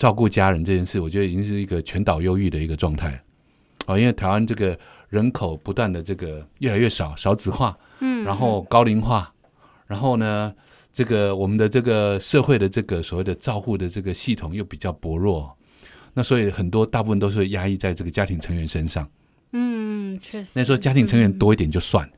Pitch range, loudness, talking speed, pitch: 90-115 Hz, -22 LUFS, 315 characters per minute, 100 Hz